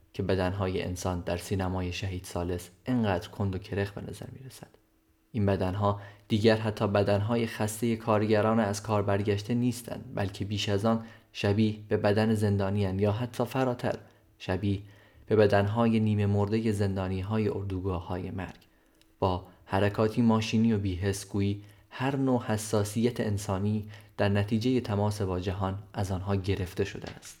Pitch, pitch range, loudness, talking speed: 105 Hz, 95-110 Hz, -29 LUFS, 140 wpm